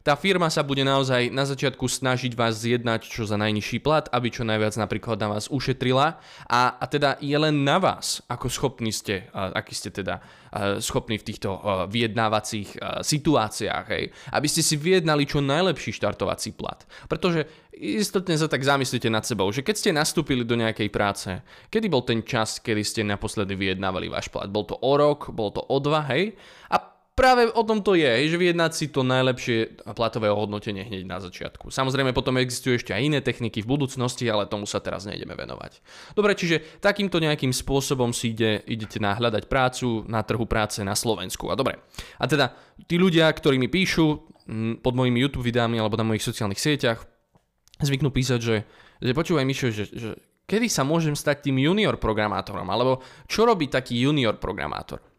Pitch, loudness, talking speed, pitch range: 125 Hz, -24 LUFS, 180 wpm, 110-145 Hz